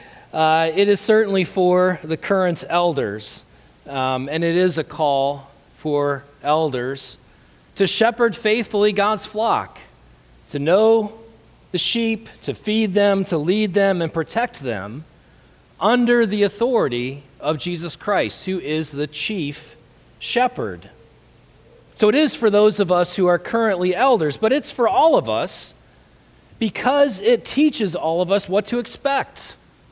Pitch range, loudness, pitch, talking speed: 150-215 Hz, -19 LUFS, 180 Hz, 140 wpm